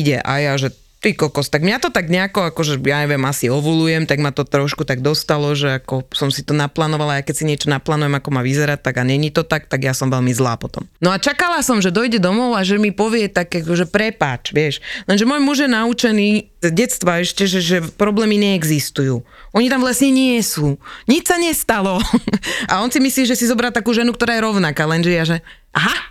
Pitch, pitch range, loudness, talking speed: 175 Hz, 145-220 Hz, -17 LUFS, 225 wpm